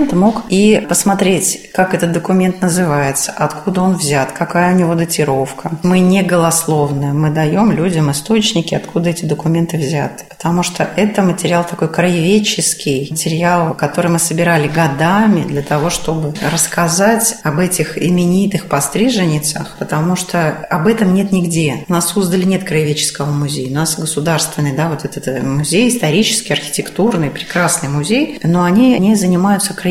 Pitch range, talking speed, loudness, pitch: 155-185 Hz, 145 wpm, -14 LUFS, 170 Hz